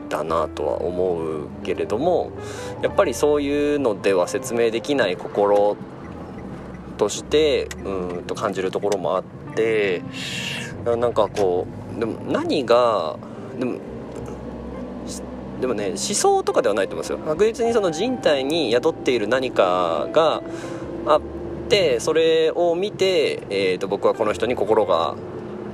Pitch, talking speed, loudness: 230 Hz, 215 characters per minute, -21 LUFS